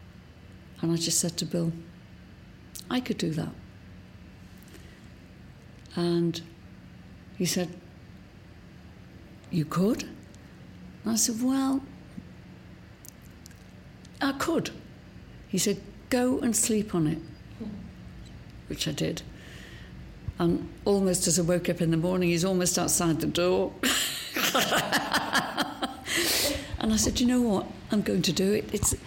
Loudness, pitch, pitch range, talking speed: -27 LUFS, 175 Hz, 145-200 Hz, 120 wpm